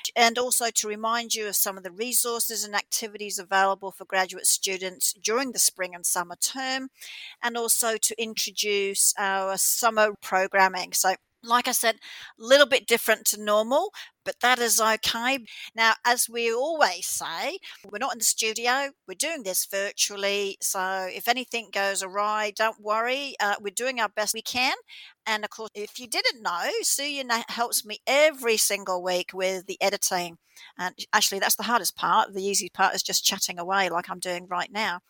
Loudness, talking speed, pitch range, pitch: -24 LUFS, 180 wpm, 195-235 Hz, 215 Hz